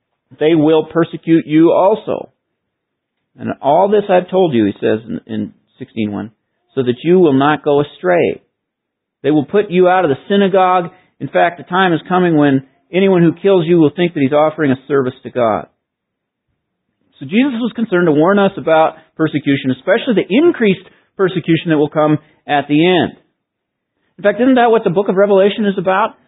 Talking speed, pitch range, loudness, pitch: 185 wpm, 145-190 Hz, -14 LUFS, 165 Hz